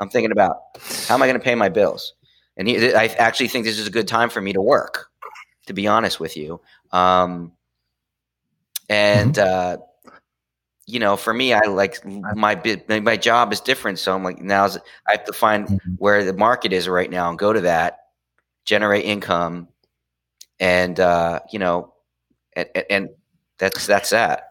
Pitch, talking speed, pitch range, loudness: 95 Hz, 180 wpm, 85-105 Hz, -19 LUFS